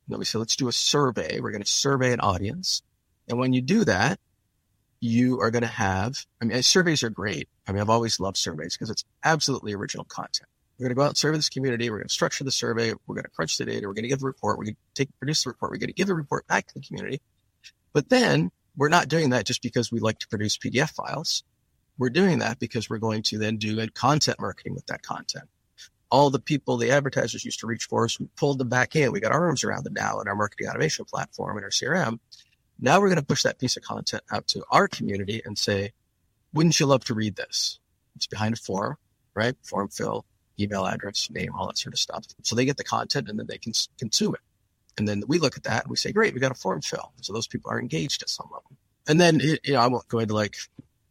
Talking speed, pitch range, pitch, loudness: 260 wpm, 105-140 Hz, 120 Hz, -25 LUFS